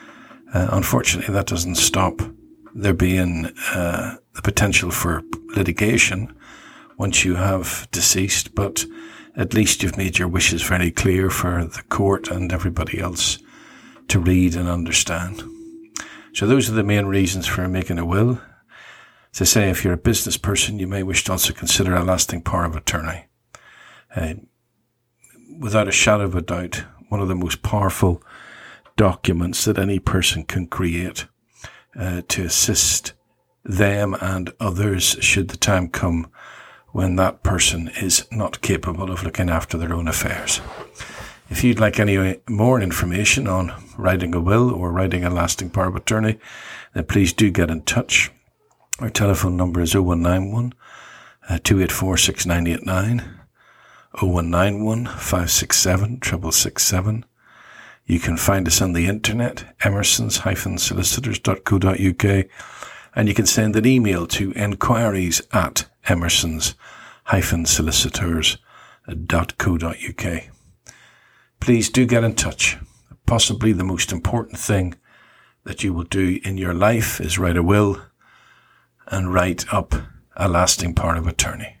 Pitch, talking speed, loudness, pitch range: 95 Hz, 135 wpm, -19 LUFS, 90-110 Hz